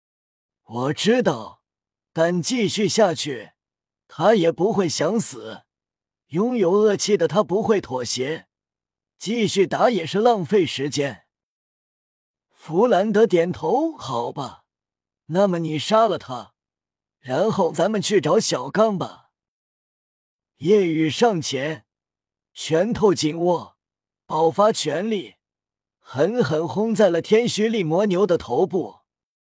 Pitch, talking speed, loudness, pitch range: 175 Hz, 160 characters per minute, -21 LUFS, 150-210 Hz